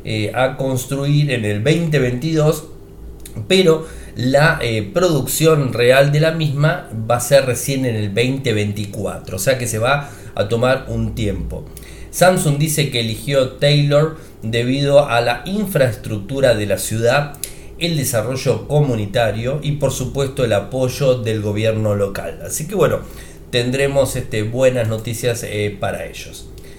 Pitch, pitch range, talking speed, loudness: 125 Hz, 110-145 Hz, 140 wpm, -17 LUFS